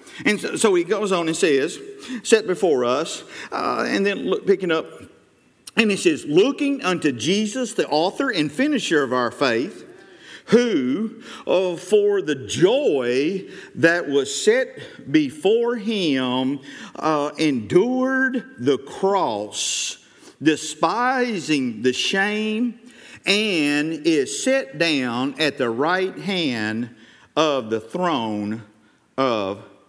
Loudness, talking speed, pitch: -21 LUFS, 115 wpm, 200 Hz